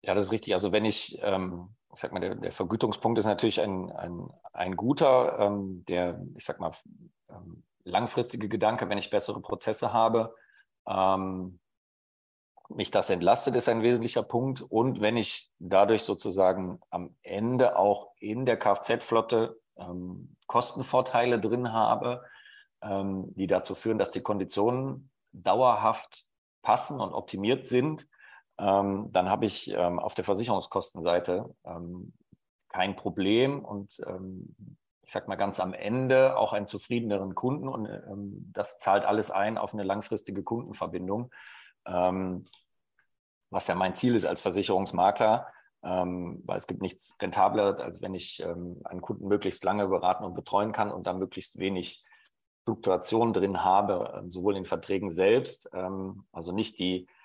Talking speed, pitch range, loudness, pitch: 150 wpm, 90-115 Hz, -29 LUFS, 100 Hz